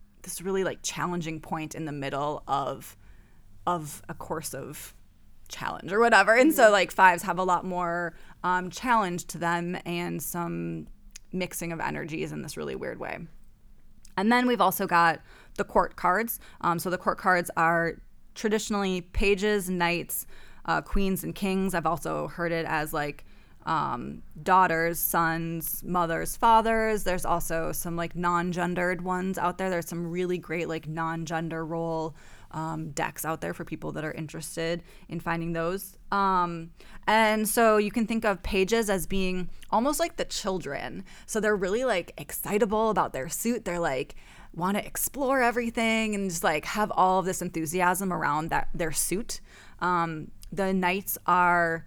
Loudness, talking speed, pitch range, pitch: -27 LUFS, 165 wpm, 165-195 Hz, 175 Hz